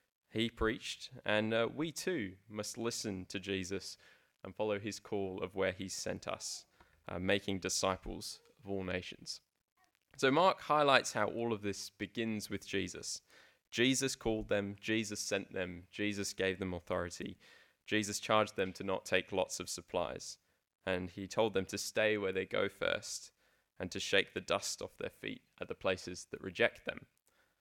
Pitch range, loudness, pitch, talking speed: 95-110 Hz, -37 LUFS, 100 Hz, 170 wpm